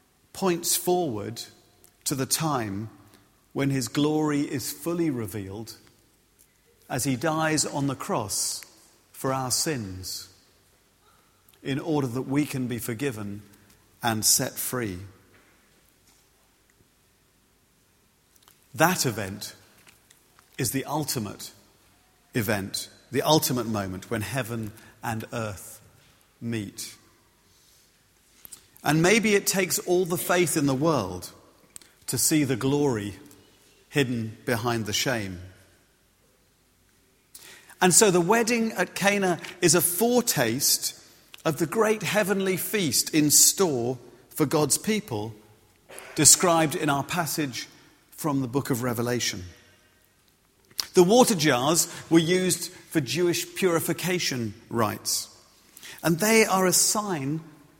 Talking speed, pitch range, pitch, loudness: 110 wpm, 110-170 Hz, 140 Hz, -24 LUFS